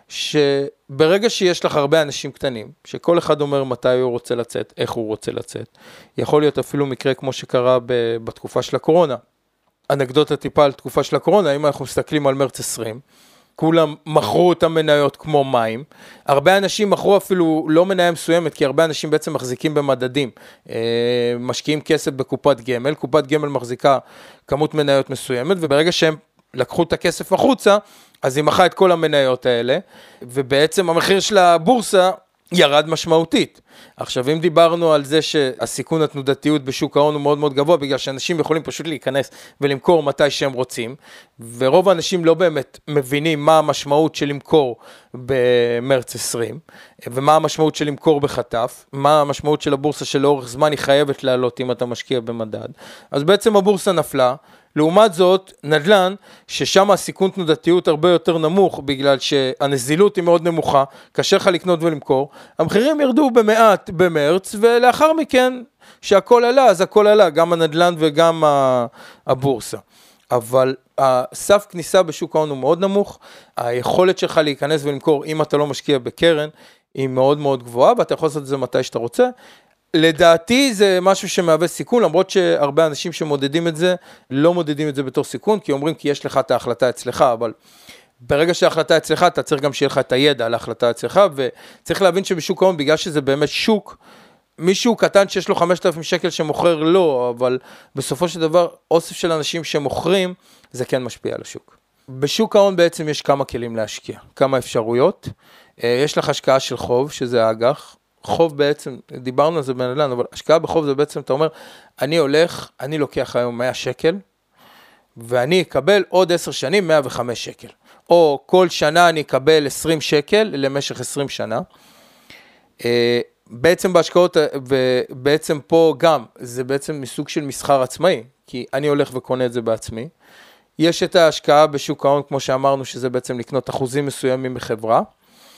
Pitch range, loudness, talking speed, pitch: 135-175 Hz, -17 LUFS, 155 wpm, 150 Hz